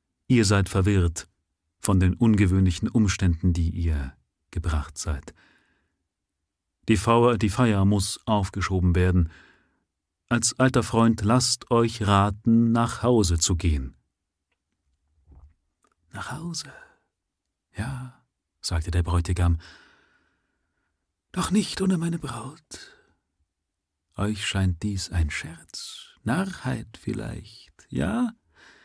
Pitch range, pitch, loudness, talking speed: 80-115 Hz, 95 Hz, -24 LUFS, 100 wpm